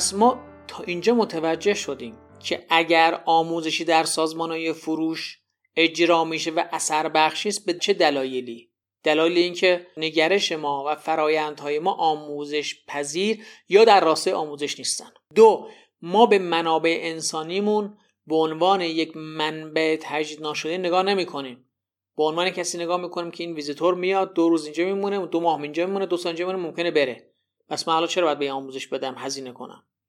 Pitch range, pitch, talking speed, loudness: 150-180 Hz, 165 Hz, 160 wpm, -22 LUFS